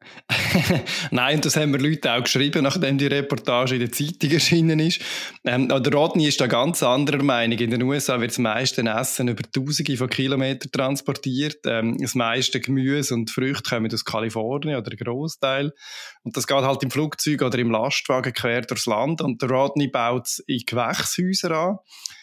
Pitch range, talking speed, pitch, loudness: 125-145 Hz, 185 wpm, 135 Hz, -22 LUFS